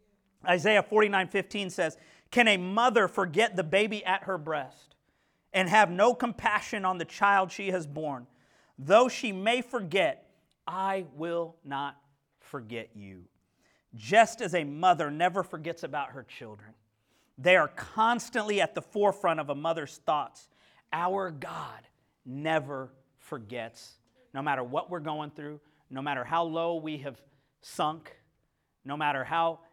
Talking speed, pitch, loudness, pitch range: 145 wpm, 170 Hz, -28 LUFS, 140-195 Hz